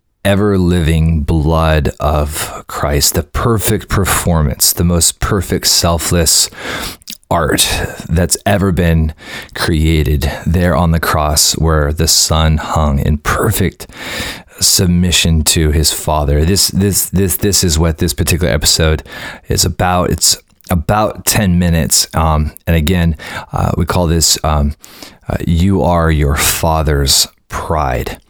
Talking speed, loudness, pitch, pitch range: 125 wpm, -12 LUFS, 85 Hz, 80-90 Hz